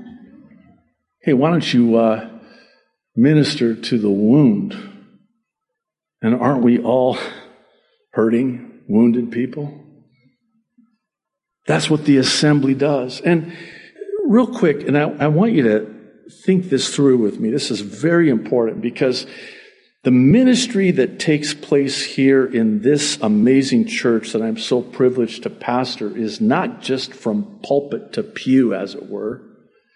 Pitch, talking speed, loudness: 140 Hz, 130 wpm, -17 LUFS